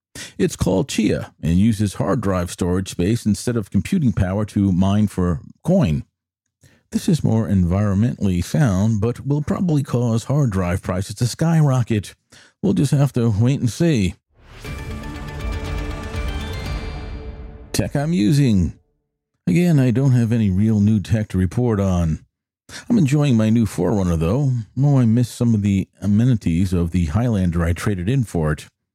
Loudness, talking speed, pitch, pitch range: -19 LUFS, 150 wpm, 105 Hz, 90-125 Hz